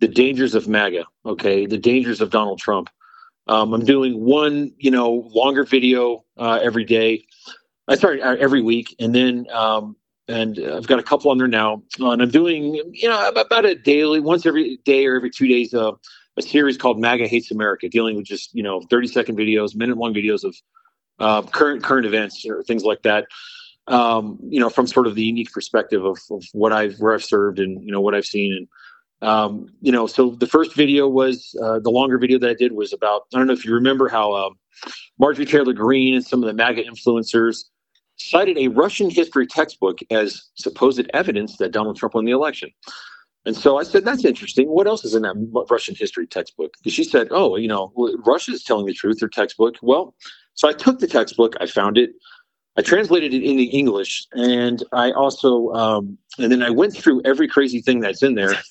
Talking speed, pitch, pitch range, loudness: 210 wpm, 125 Hz, 110-140 Hz, -18 LUFS